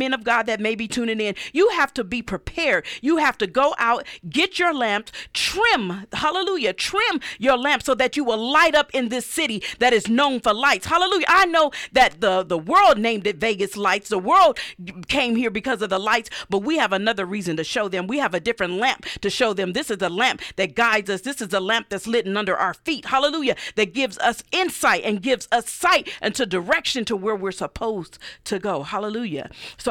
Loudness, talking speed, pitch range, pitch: -21 LUFS, 225 wpm, 205-285 Hz, 235 Hz